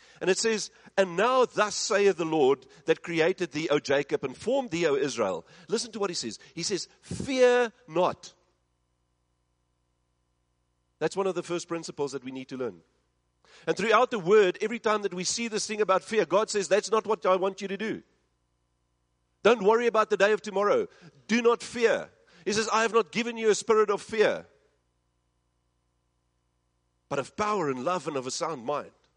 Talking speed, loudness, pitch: 190 wpm, -27 LUFS, 180 Hz